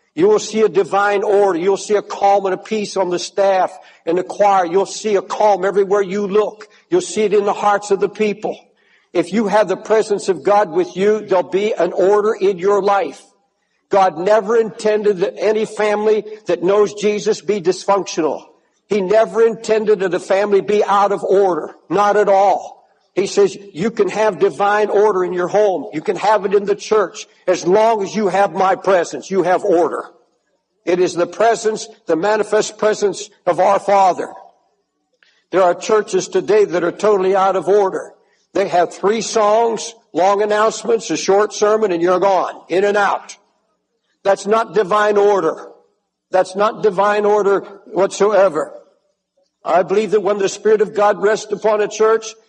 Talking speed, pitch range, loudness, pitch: 180 wpm, 195-215 Hz, -16 LUFS, 205 Hz